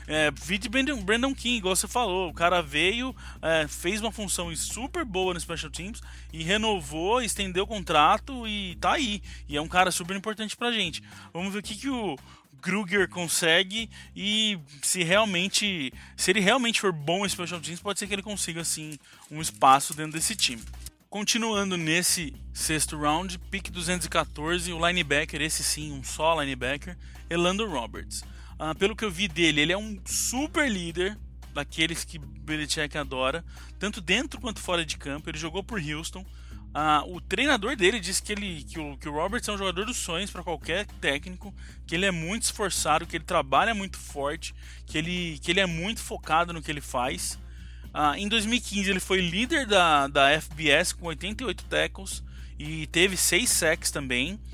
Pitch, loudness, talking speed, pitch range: 175 Hz, -26 LUFS, 180 wpm, 155-205 Hz